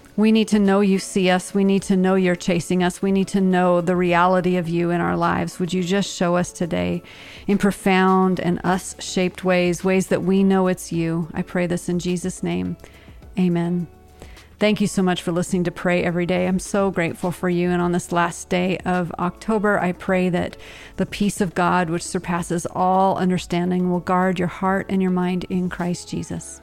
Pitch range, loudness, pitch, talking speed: 175-190 Hz, -21 LUFS, 180 Hz, 210 wpm